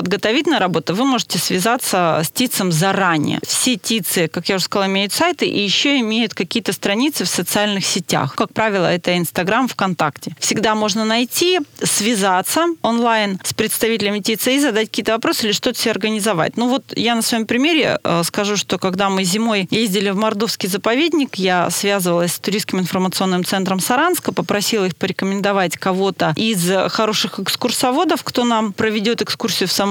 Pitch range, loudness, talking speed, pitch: 190-230 Hz, -17 LUFS, 160 wpm, 210 Hz